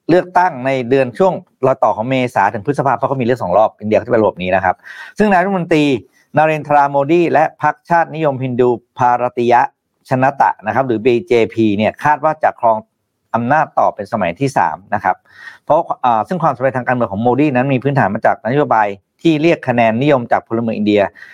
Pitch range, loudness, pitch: 120-150 Hz, -15 LUFS, 130 Hz